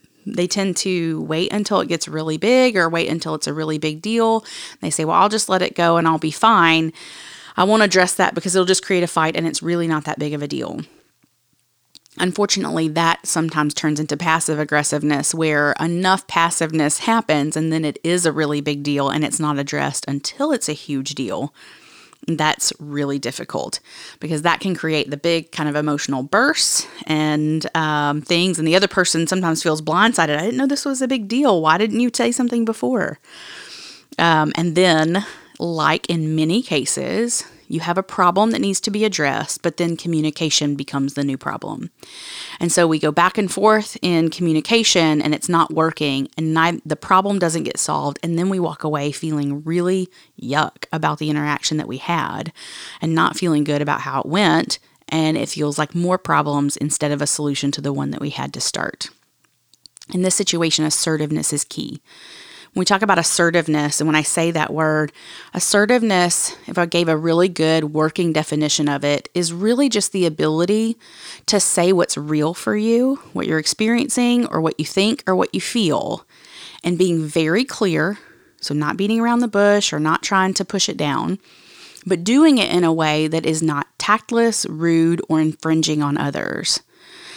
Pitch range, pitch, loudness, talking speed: 155-190 Hz, 165 Hz, -18 LUFS, 190 wpm